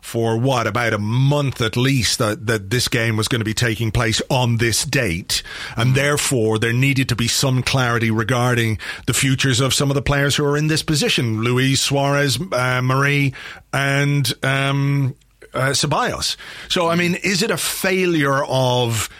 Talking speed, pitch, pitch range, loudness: 180 wpm, 130 Hz, 115-140 Hz, -18 LUFS